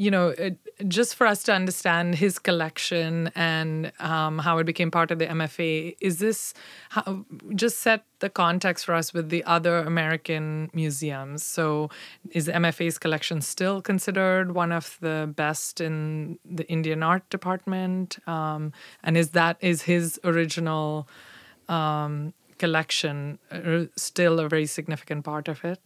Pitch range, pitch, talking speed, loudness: 160-185 Hz, 170 Hz, 150 wpm, -26 LUFS